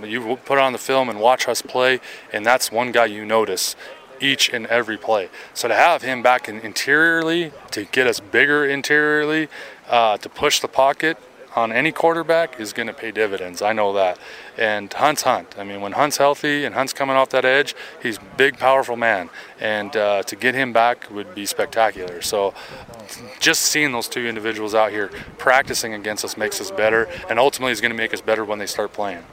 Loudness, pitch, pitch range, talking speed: -19 LUFS, 120 Hz, 110-140 Hz, 205 wpm